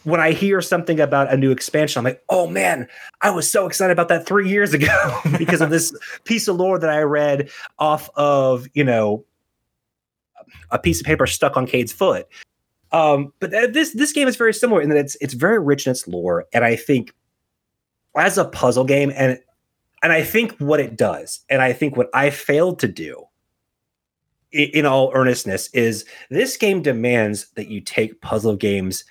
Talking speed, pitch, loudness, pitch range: 190 wpm, 145 Hz, -18 LUFS, 125-170 Hz